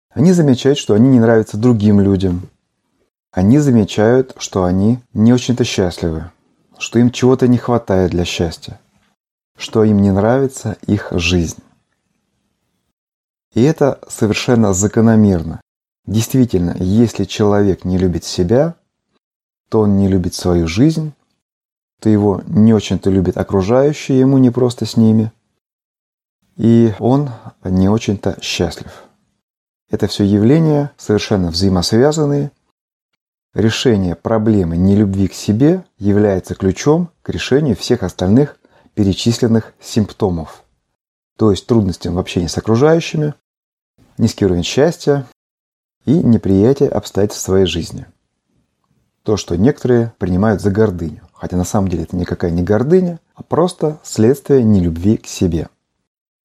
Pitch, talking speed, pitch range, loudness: 110 Hz, 120 wpm, 95-125 Hz, -14 LUFS